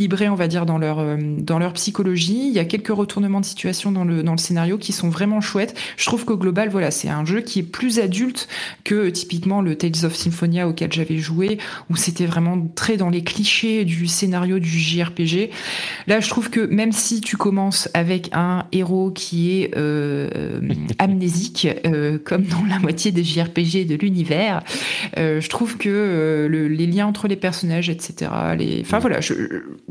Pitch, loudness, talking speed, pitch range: 180 Hz, -20 LUFS, 195 wpm, 170-205 Hz